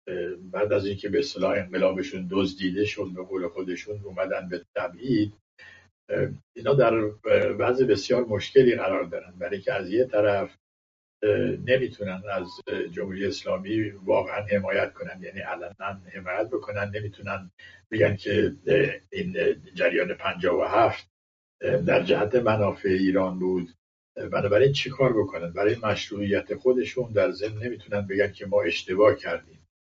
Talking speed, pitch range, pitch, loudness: 130 wpm, 90-105 Hz, 100 Hz, -26 LUFS